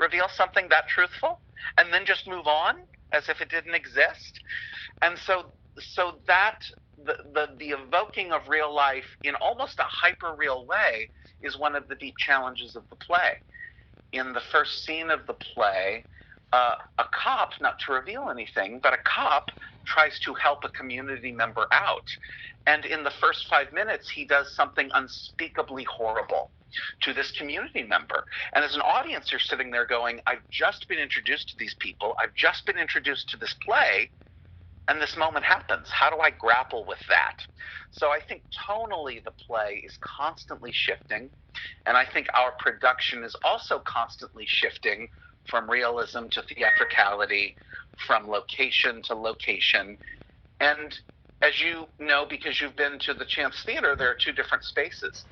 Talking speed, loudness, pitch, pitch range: 165 wpm, -25 LUFS, 155 Hz, 135-200 Hz